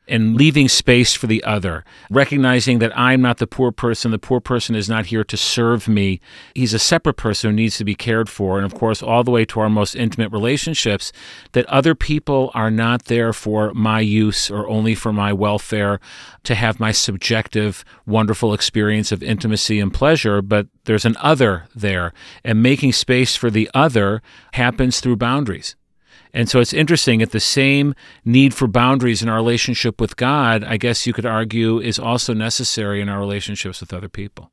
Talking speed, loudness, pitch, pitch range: 190 wpm, -17 LUFS, 115 Hz, 105-125 Hz